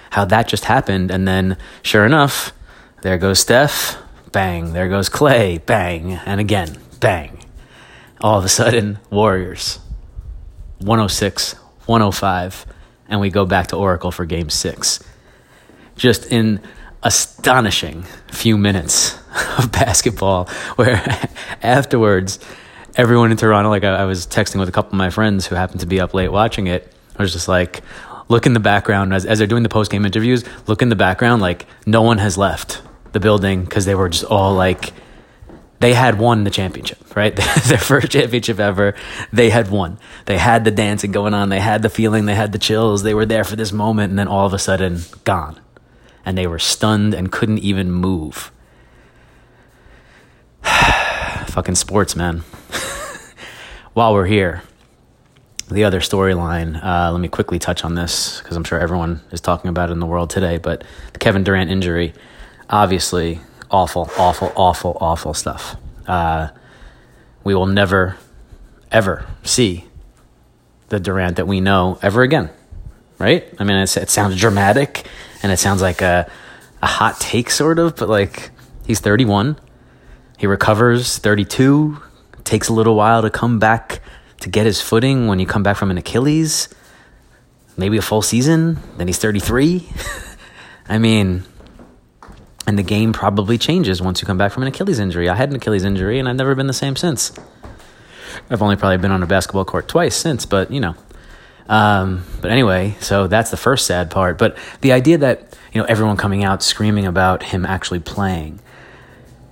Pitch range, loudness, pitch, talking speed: 90-110 Hz, -16 LUFS, 100 Hz, 170 wpm